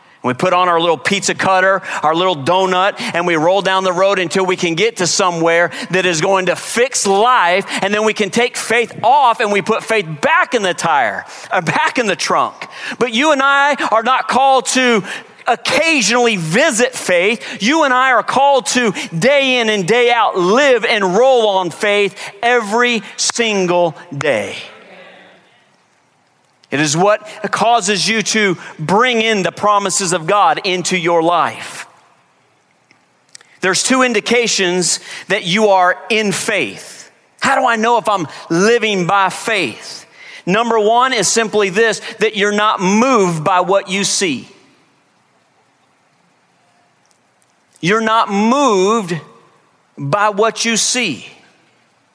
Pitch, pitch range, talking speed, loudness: 210 Hz, 185-235 Hz, 150 wpm, -14 LUFS